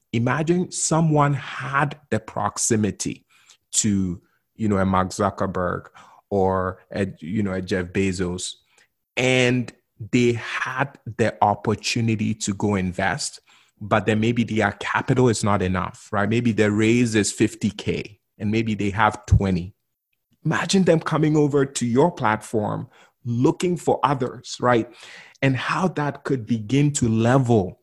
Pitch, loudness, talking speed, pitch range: 115 Hz, -22 LUFS, 135 wpm, 100-135 Hz